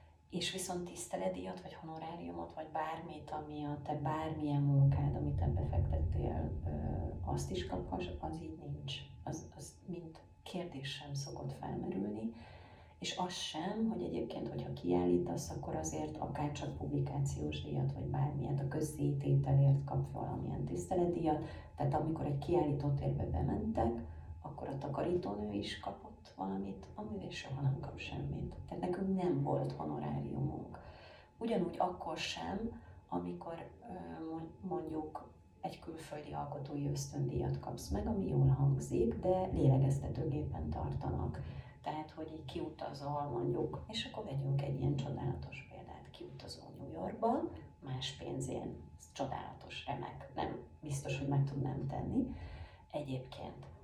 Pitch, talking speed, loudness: 130 Hz, 125 wpm, -39 LUFS